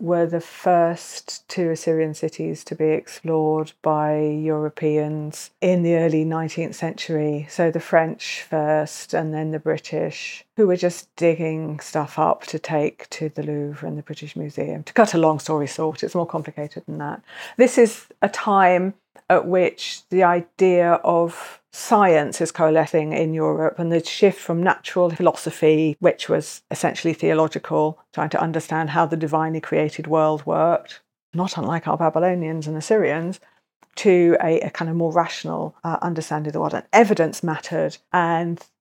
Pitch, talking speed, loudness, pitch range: 165 Hz, 160 wpm, -21 LUFS, 155-175 Hz